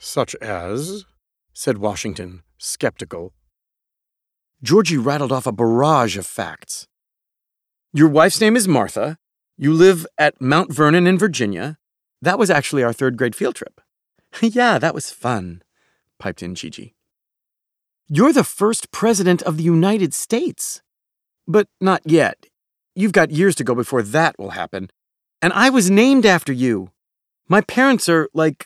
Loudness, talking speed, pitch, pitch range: -17 LUFS, 145 wpm, 155 Hz, 115-190 Hz